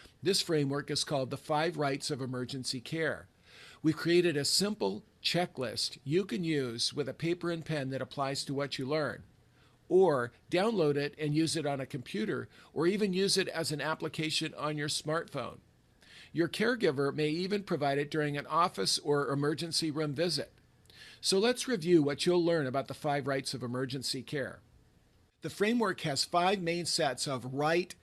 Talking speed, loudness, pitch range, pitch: 175 wpm, -32 LUFS, 140-170 Hz, 150 Hz